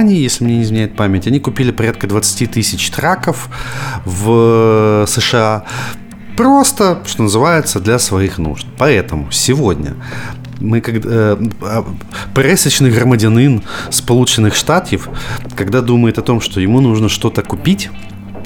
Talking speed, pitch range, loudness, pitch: 125 wpm, 105-125 Hz, -13 LUFS, 115 Hz